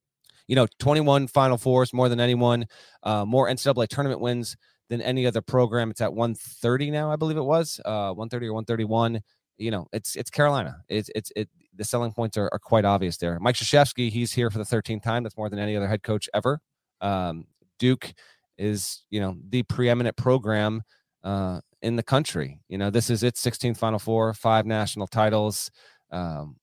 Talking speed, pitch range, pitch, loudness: 200 wpm, 105-125 Hz, 115 Hz, -25 LUFS